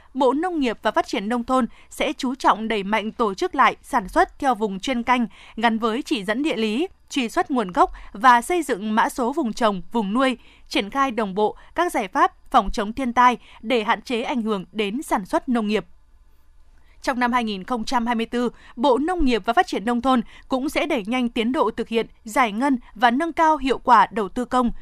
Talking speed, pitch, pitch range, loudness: 220 wpm, 245 Hz, 220-275 Hz, -22 LUFS